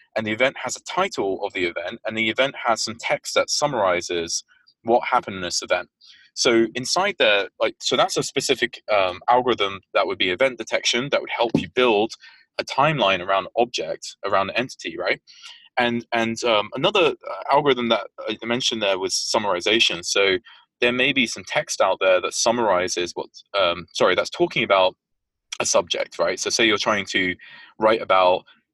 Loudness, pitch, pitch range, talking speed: -21 LUFS, 115 Hz, 110-135 Hz, 185 wpm